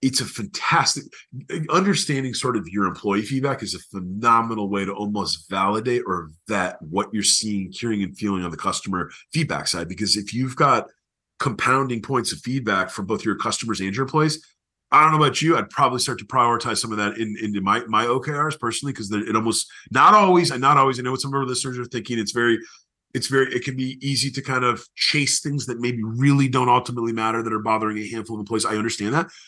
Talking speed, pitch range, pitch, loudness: 220 wpm, 105-135 Hz, 120 Hz, -21 LUFS